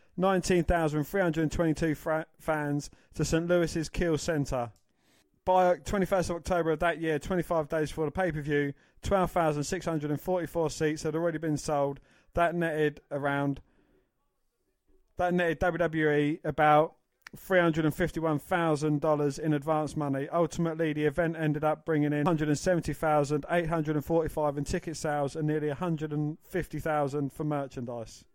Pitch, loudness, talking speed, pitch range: 155 Hz, -29 LUFS, 160 wpm, 150-170 Hz